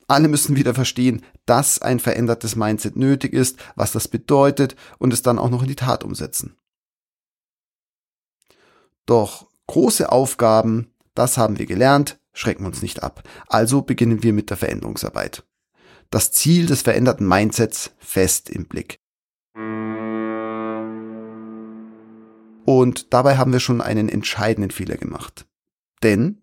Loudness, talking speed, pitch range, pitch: -19 LUFS, 130 wpm, 110-130 Hz, 115 Hz